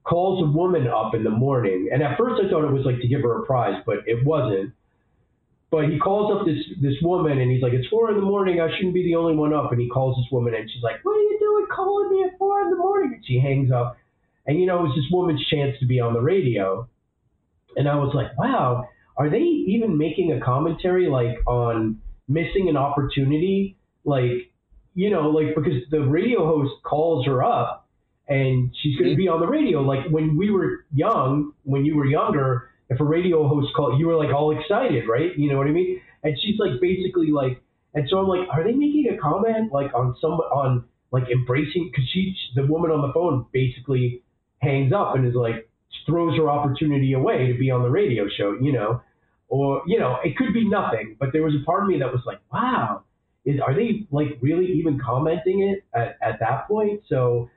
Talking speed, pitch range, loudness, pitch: 225 wpm, 125-175 Hz, -22 LUFS, 145 Hz